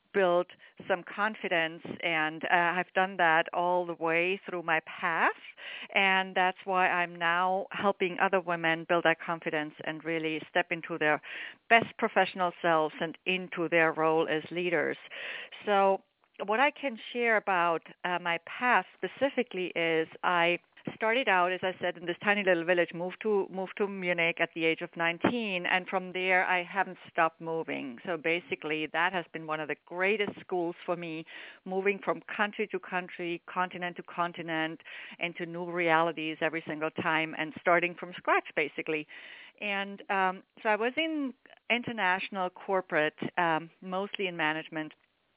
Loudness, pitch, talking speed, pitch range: -30 LUFS, 180 Hz, 160 wpm, 165-190 Hz